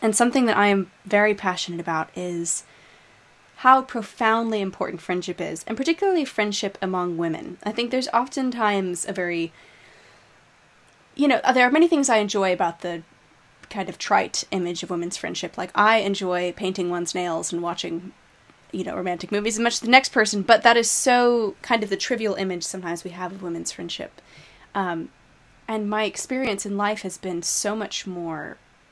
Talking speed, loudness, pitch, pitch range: 180 wpm, -23 LUFS, 200 Hz, 180-225 Hz